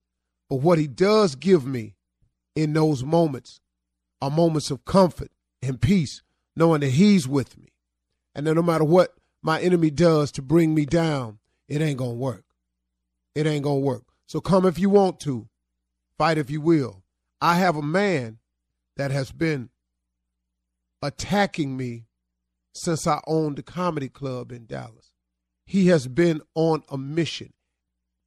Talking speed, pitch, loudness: 155 wpm, 140 Hz, -23 LUFS